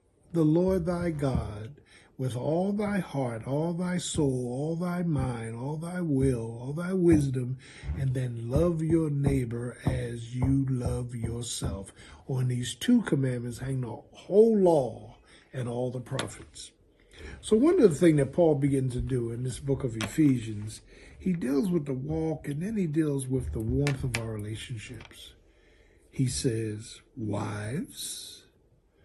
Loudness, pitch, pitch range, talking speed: -29 LUFS, 130 Hz, 120-160 Hz, 155 wpm